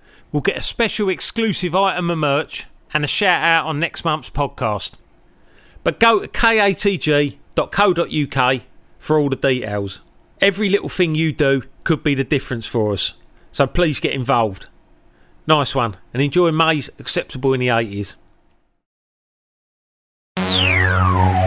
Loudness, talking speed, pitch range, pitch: -18 LUFS, 135 wpm, 120-170 Hz, 145 Hz